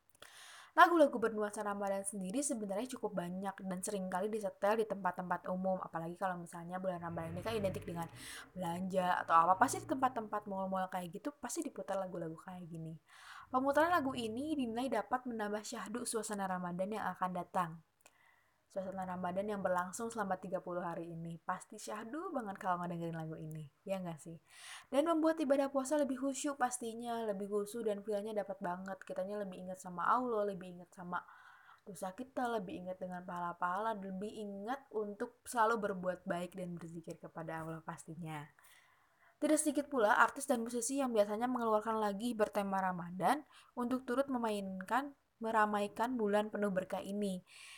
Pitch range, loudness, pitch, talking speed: 185-240 Hz, -37 LUFS, 205 Hz, 155 wpm